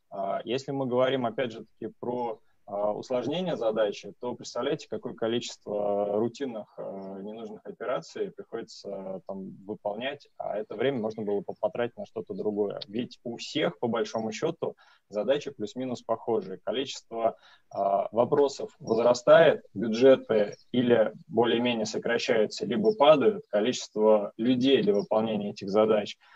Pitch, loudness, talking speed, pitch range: 115 Hz, -28 LUFS, 130 wpm, 105-125 Hz